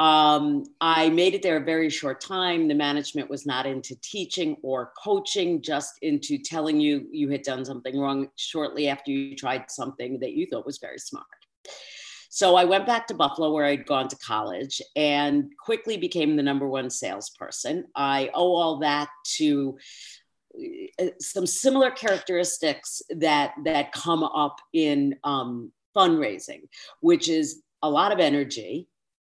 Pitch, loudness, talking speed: 155 Hz, -25 LUFS, 155 wpm